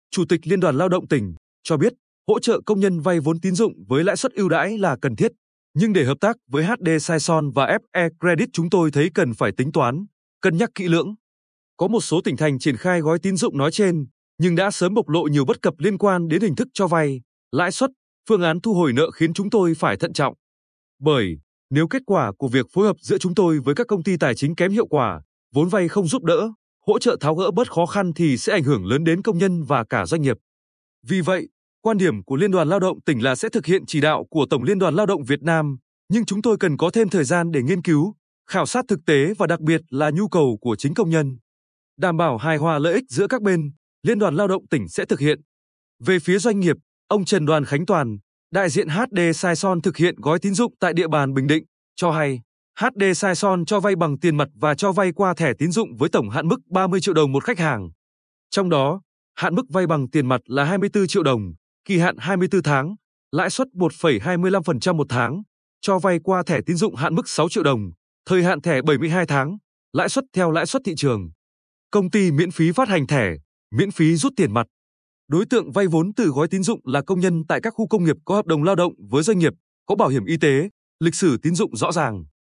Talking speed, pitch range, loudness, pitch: 245 wpm, 145-195 Hz, -20 LUFS, 170 Hz